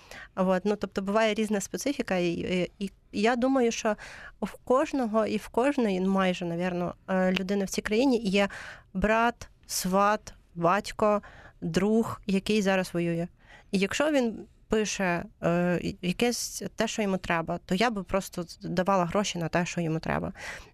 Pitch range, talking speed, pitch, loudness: 180-220 Hz, 155 wpm, 200 Hz, -28 LUFS